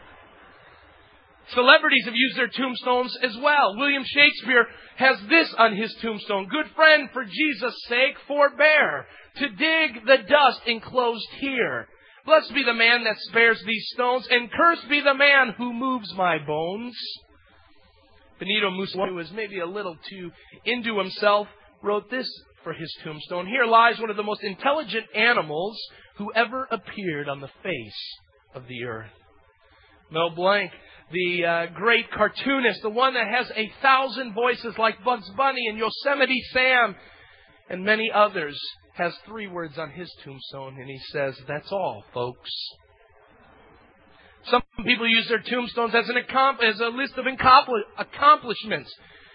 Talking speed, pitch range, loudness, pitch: 150 wpm, 190-260 Hz, -22 LUFS, 230 Hz